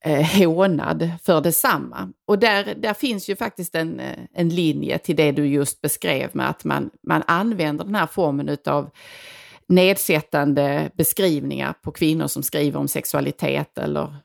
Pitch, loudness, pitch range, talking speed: 165 Hz, -21 LUFS, 145-195 Hz, 145 wpm